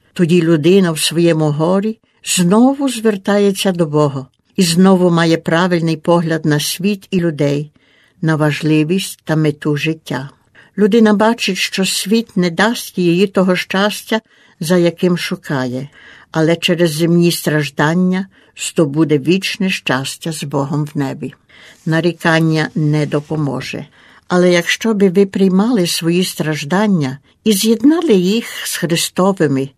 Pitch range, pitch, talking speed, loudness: 155-195 Hz, 170 Hz, 125 wpm, -14 LUFS